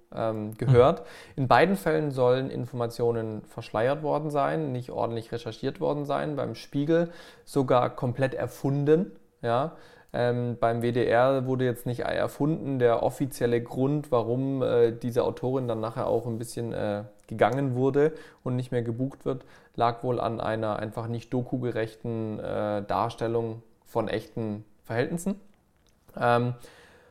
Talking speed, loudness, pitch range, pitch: 135 wpm, -27 LUFS, 115-140 Hz, 120 Hz